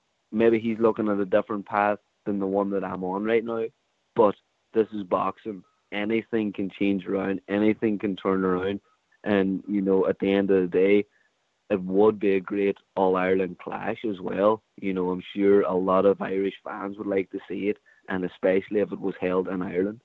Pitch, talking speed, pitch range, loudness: 100 Hz, 205 wpm, 95-105 Hz, -25 LUFS